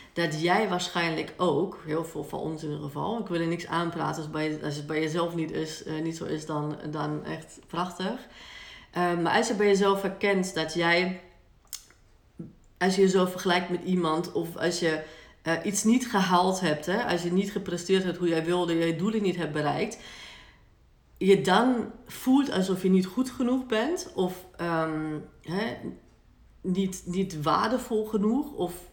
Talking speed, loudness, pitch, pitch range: 175 wpm, -27 LUFS, 180 Hz, 165-195 Hz